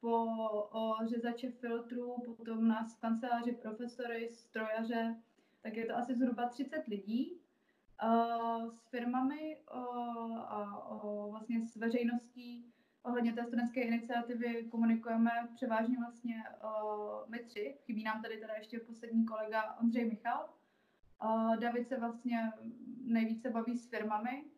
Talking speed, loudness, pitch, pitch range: 115 wpm, -38 LUFS, 235 Hz, 225-240 Hz